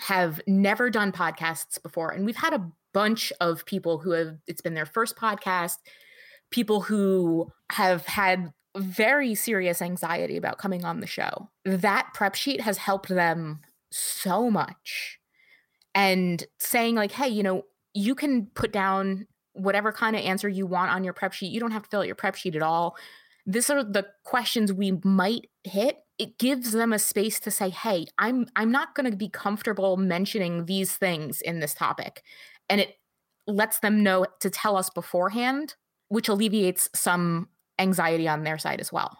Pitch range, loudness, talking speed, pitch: 180-220 Hz, -26 LUFS, 180 wpm, 195 Hz